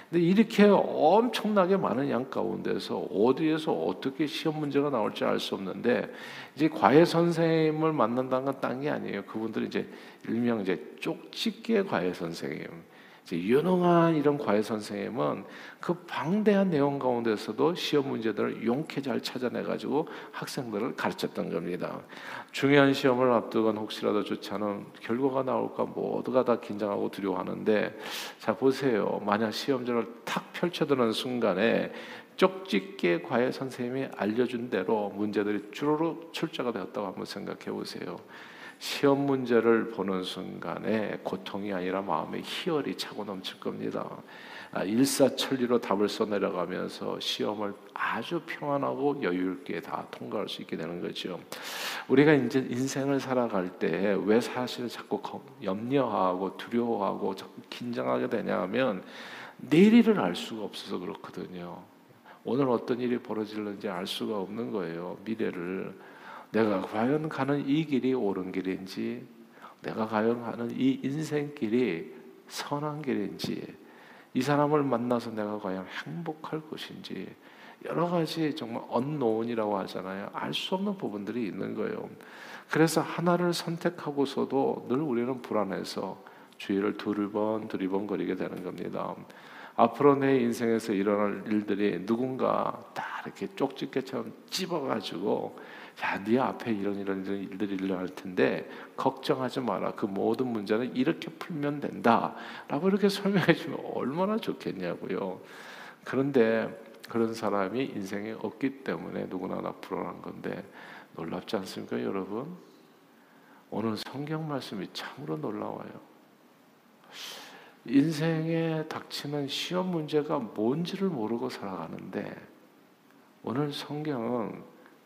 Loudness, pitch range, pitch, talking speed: -30 LUFS, 105-150 Hz, 125 Hz, 305 characters per minute